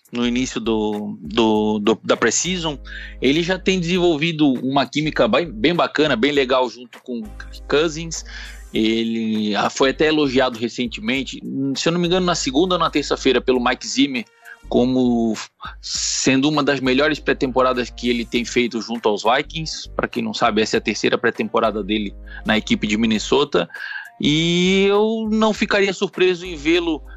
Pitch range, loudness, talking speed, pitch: 120-180 Hz, -19 LUFS, 160 wpm, 135 Hz